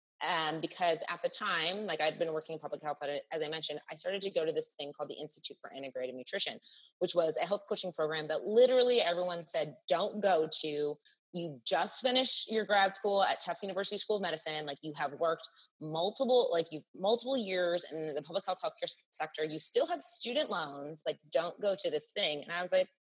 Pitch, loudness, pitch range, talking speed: 170 Hz, -29 LUFS, 155-205 Hz, 220 wpm